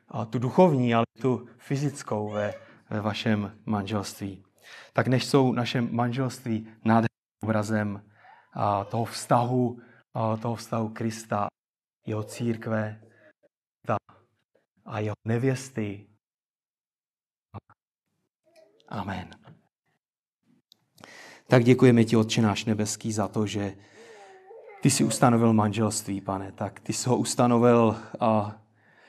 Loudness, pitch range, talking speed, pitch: -26 LUFS, 105-120 Hz, 105 wpm, 115 Hz